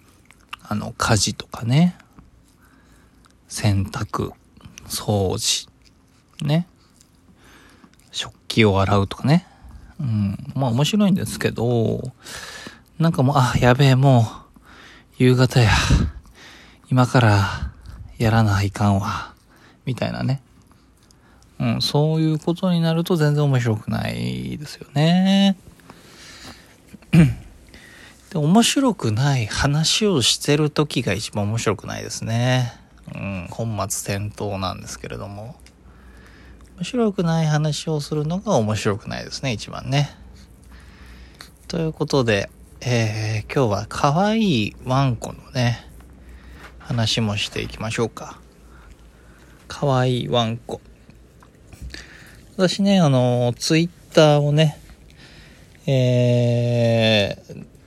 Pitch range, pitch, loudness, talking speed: 100-150 Hz, 120 Hz, -20 LUFS, 200 characters per minute